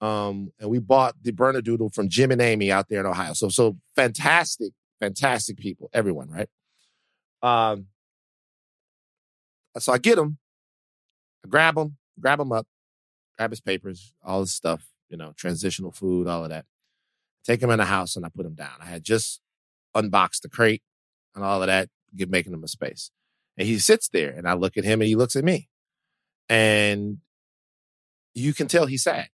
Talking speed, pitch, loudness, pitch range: 185 wpm, 105 Hz, -23 LUFS, 95-120 Hz